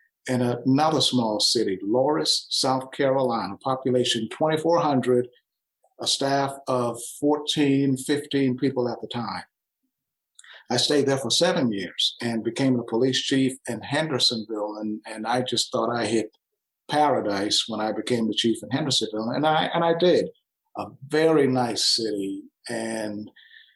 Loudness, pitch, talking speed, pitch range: -24 LUFS, 125 Hz, 140 wpm, 115-140 Hz